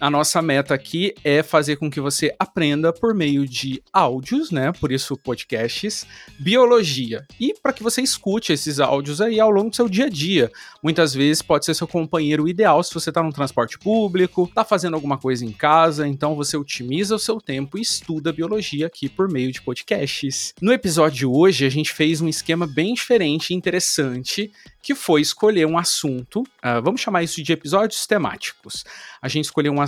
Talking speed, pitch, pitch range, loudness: 195 wpm, 160 Hz, 145-195 Hz, -20 LUFS